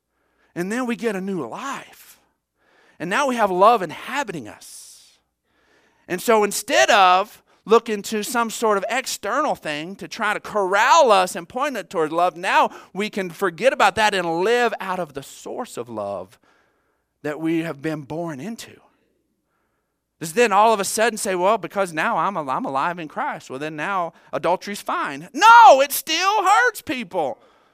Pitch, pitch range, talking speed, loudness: 205 Hz, 180-240 Hz, 170 wpm, -19 LUFS